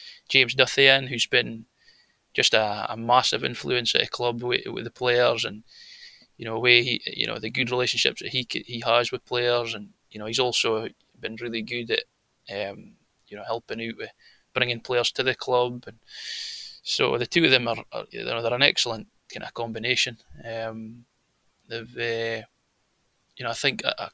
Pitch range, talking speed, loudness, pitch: 115-125 Hz, 190 wpm, -24 LUFS, 120 Hz